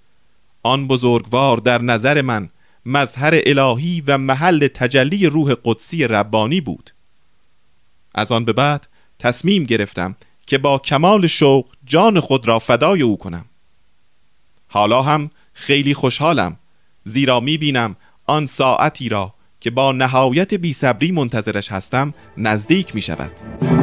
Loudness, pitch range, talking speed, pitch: -16 LUFS, 105-145 Hz, 125 wpm, 125 Hz